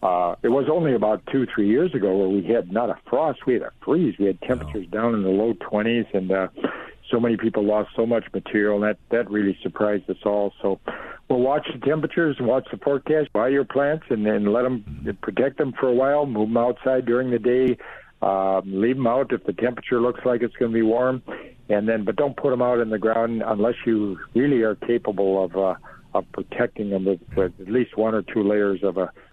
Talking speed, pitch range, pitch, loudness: 235 wpm, 105-125 Hz, 115 Hz, -22 LUFS